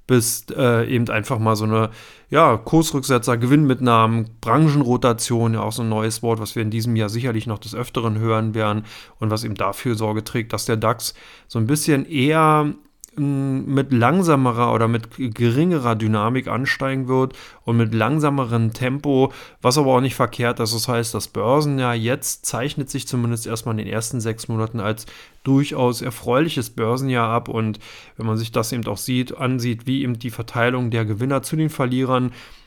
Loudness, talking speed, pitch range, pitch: -20 LUFS, 175 wpm, 115-130 Hz, 120 Hz